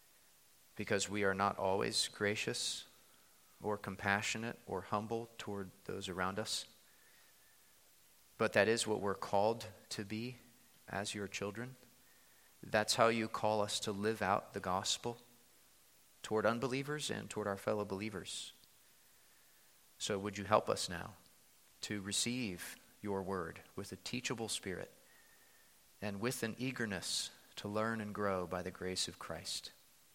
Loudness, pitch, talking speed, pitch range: -38 LUFS, 105 Hz, 135 wpm, 100-115 Hz